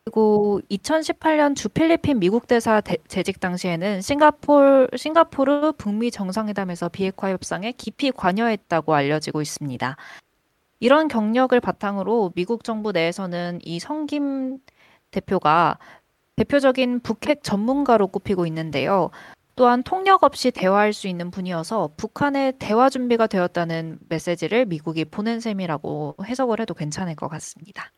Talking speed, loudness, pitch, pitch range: 320 characters per minute, -21 LUFS, 215 Hz, 175-255 Hz